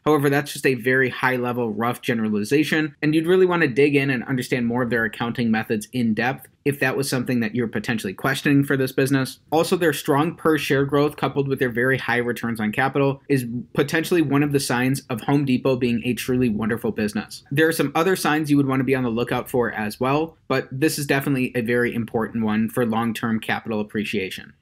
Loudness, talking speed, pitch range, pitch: -22 LUFS, 220 wpm, 120-145 Hz, 130 Hz